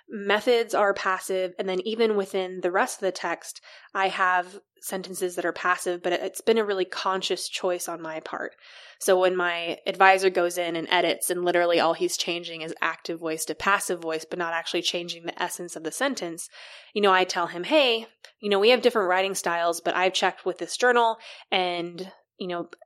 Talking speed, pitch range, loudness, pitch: 205 wpm, 175-195 Hz, -25 LUFS, 185 Hz